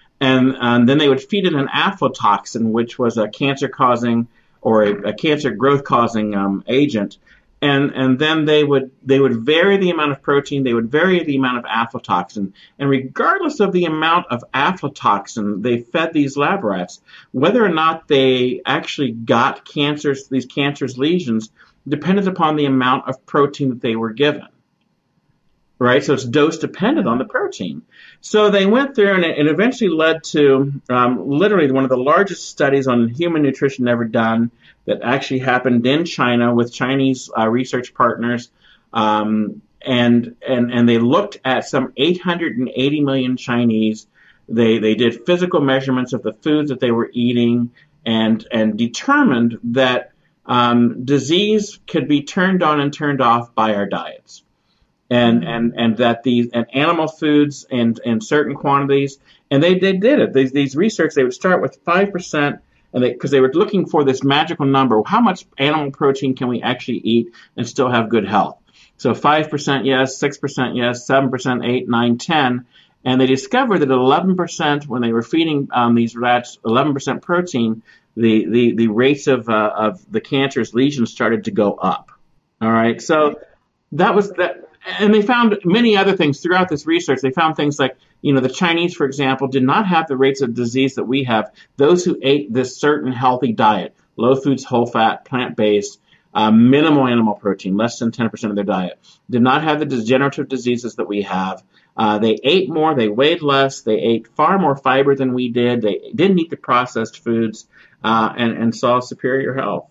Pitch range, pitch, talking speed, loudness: 120-150 Hz, 130 Hz, 180 wpm, -17 LUFS